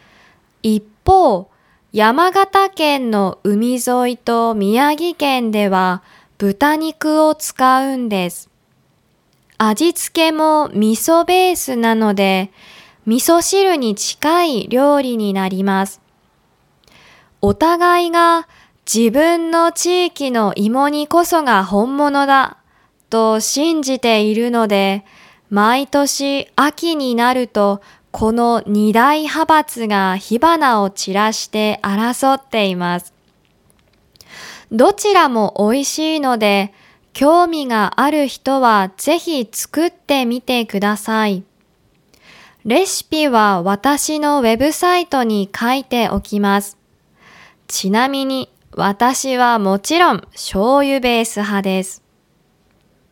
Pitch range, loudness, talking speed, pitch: 205-295 Hz, -15 LUFS, 190 characters per minute, 240 Hz